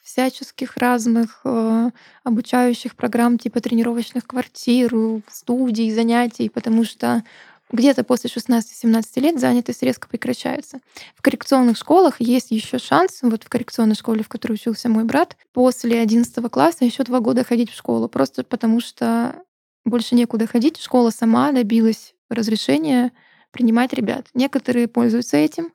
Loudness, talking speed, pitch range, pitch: -19 LUFS, 135 wpm, 230-255 Hz, 240 Hz